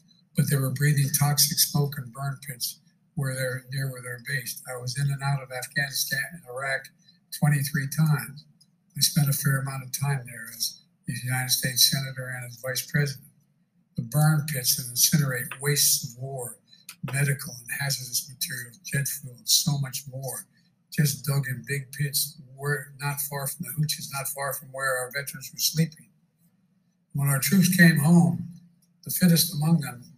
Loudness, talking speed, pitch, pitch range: -25 LUFS, 175 wpm, 145 Hz, 135-160 Hz